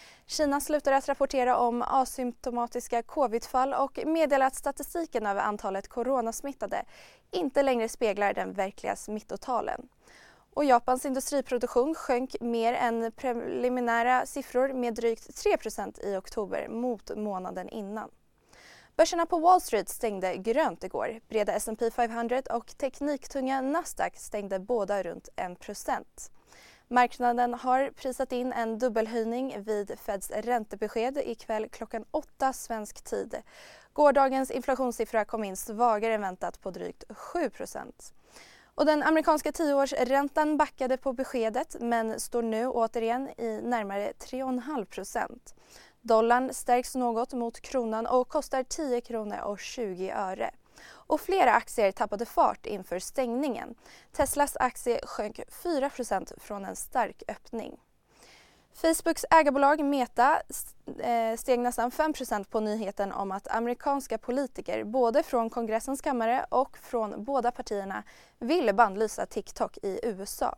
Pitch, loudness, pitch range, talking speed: 245 Hz, -29 LUFS, 225-275 Hz, 120 wpm